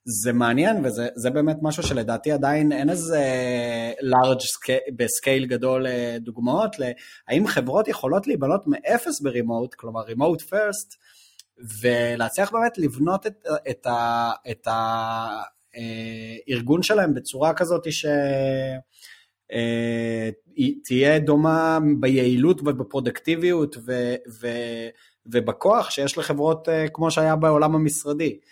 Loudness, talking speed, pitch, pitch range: -23 LUFS, 100 wpm, 135 Hz, 120-155 Hz